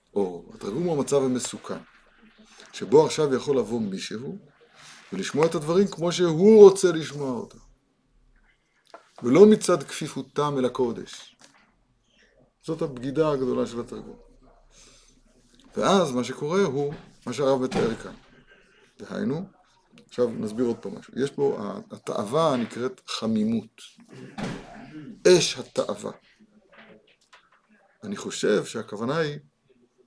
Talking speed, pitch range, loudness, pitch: 105 wpm, 130-200 Hz, -24 LUFS, 160 Hz